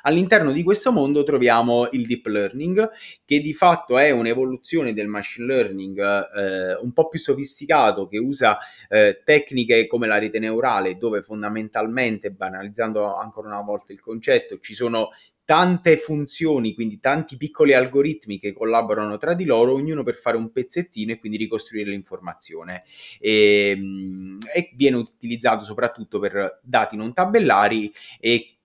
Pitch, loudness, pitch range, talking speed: 115 Hz, -21 LUFS, 105-145 Hz, 145 wpm